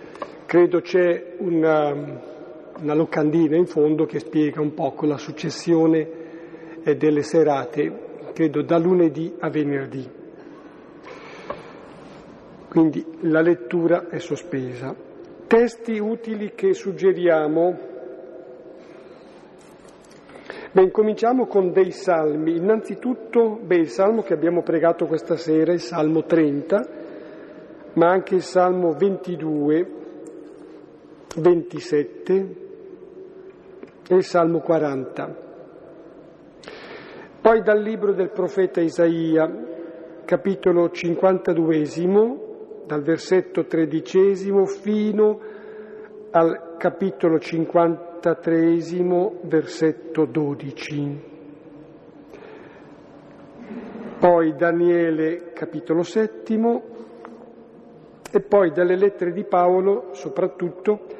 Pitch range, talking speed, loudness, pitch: 160-195 Hz, 80 wpm, -21 LUFS, 170 Hz